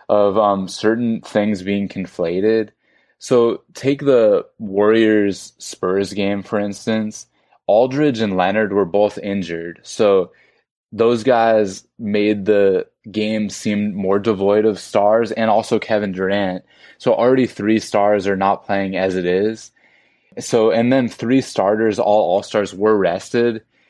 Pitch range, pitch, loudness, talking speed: 100-110 Hz, 105 Hz, -17 LUFS, 140 wpm